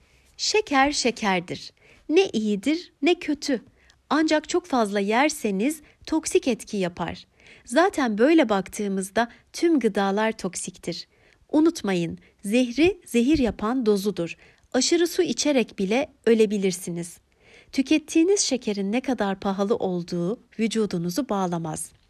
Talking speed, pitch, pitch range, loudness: 100 wpm, 230 Hz, 195-295 Hz, -24 LUFS